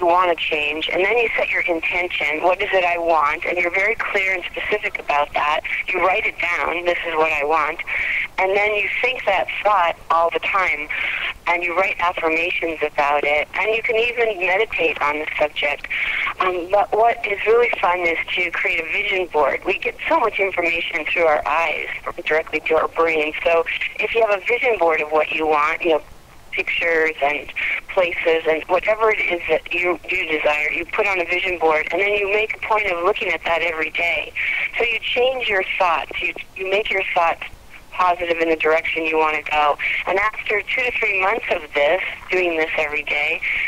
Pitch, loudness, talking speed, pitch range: 175 Hz, -19 LUFS, 205 wpm, 160-205 Hz